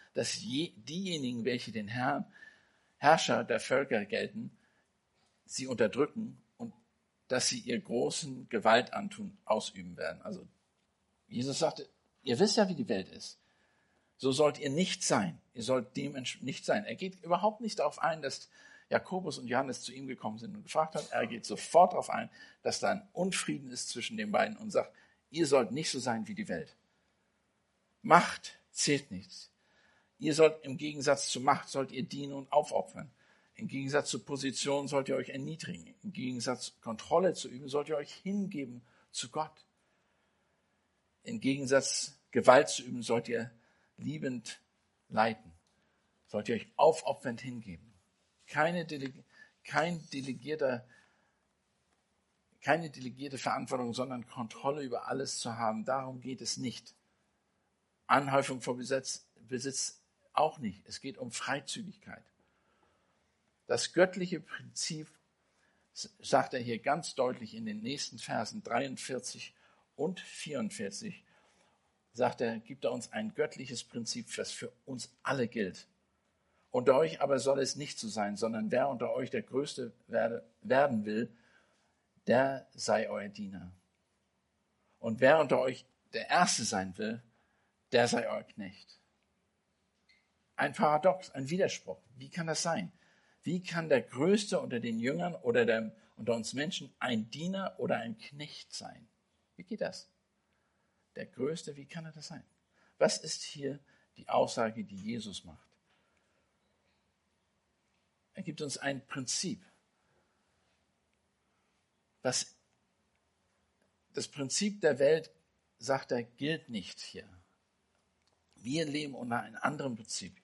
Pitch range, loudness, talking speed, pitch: 125-175 Hz, -33 LUFS, 140 wpm, 140 Hz